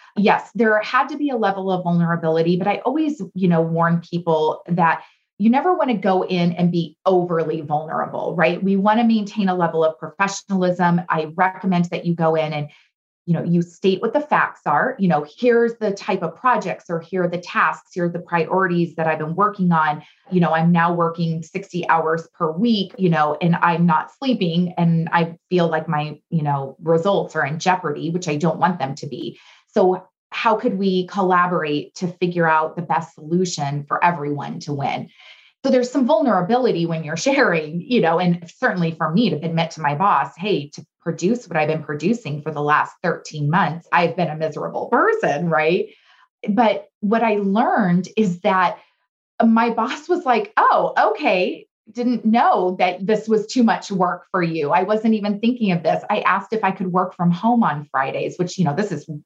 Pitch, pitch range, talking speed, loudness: 175 Hz, 165-205 Hz, 200 wpm, -20 LUFS